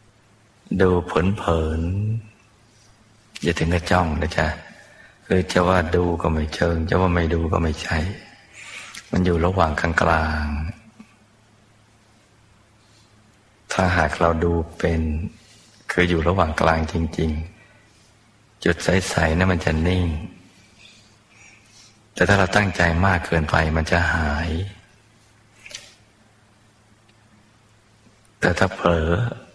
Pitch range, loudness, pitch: 85-110 Hz, -21 LUFS, 95 Hz